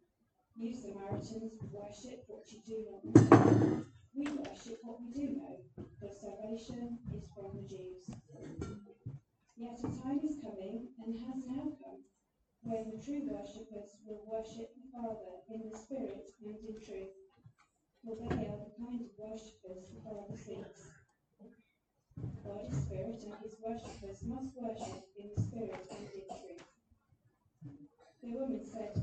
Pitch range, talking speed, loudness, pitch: 205-240 Hz, 150 wpm, -38 LUFS, 220 Hz